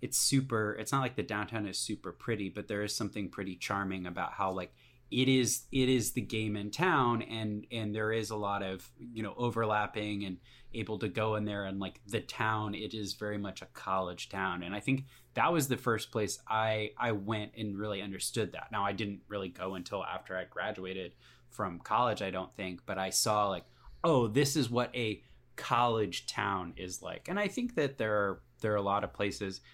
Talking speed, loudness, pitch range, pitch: 220 wpm, -34 LUFS, 100-115 Hz, 105 Hz